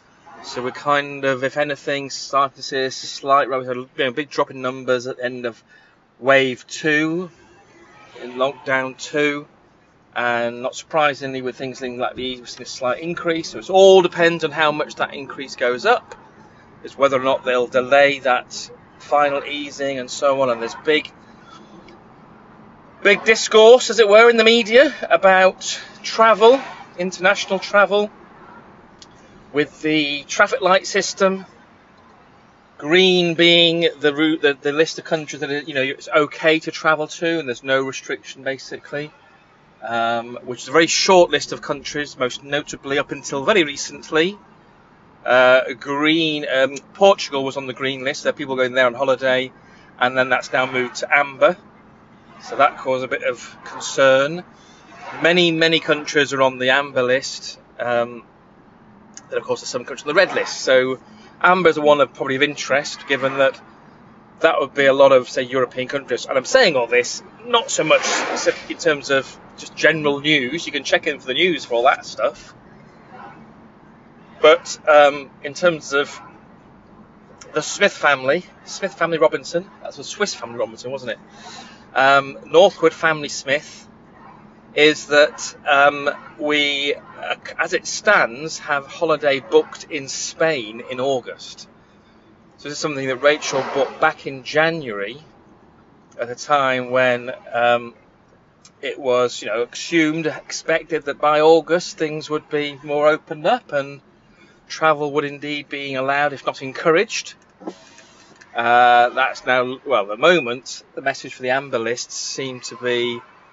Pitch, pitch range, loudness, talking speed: 145 Hz, 130-160 Hz, -18 LUFS, 160 wpm